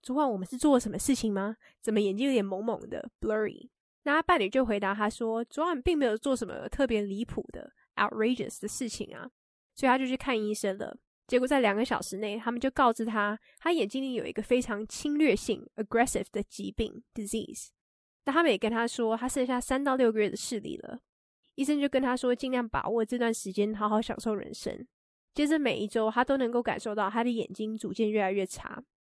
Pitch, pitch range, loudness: 230 Hz, 215-260 Hz, -30 LUFS